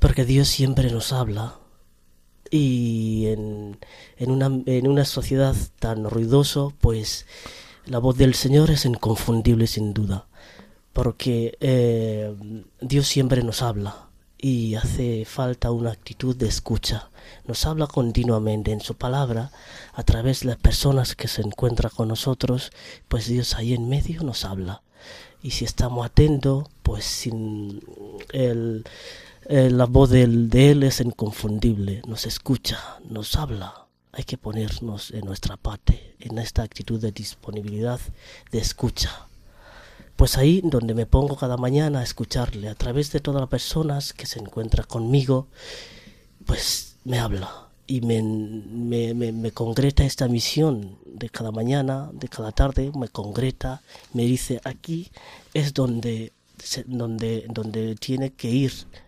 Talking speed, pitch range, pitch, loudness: 140 wpm, 110-130 Hz, 120 Hz, -23 LUFS